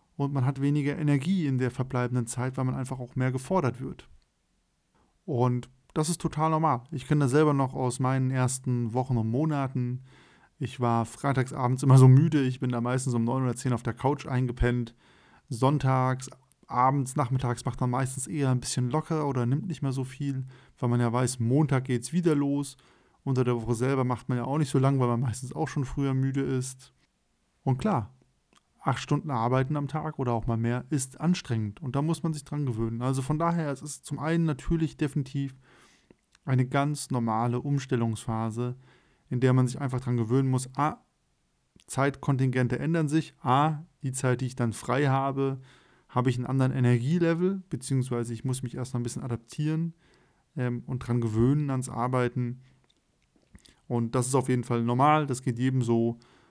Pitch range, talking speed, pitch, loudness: 125-140 Hz, 190 wpm, 130 Hz, -28 LUFS